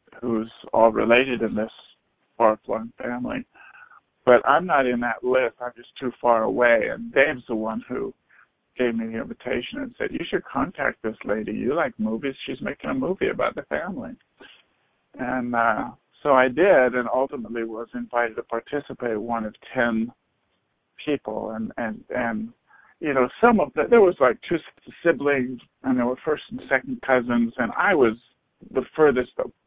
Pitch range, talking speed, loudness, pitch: 115-130 Hz, 175 wpm, -23 LUFS, 120 Hz